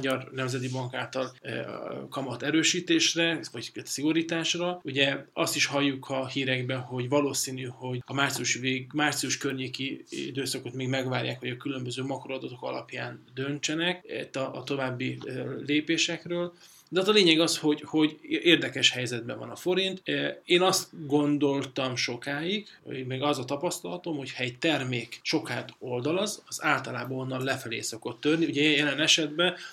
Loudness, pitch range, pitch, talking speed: -28 LUFS, 130-160 Hz, 140 Hz, 140 wpm